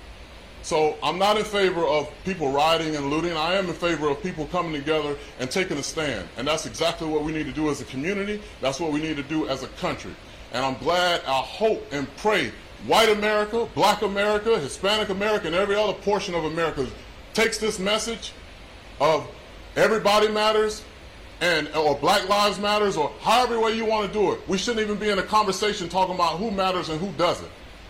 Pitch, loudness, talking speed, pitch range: 175 Hz, -24 LUFS, 200 wpm, 150-210 Hz